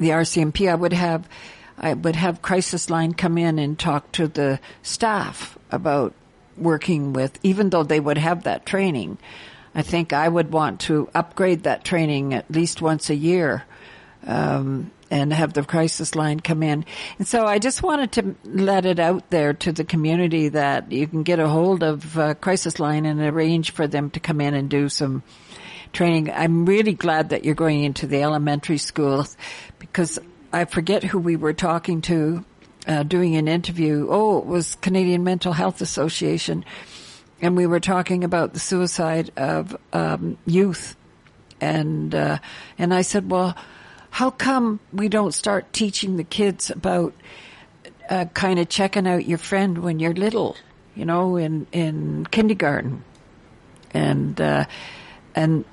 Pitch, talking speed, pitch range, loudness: 165 Hz, 165 wpm, 155-180 Hz, -21 LUFS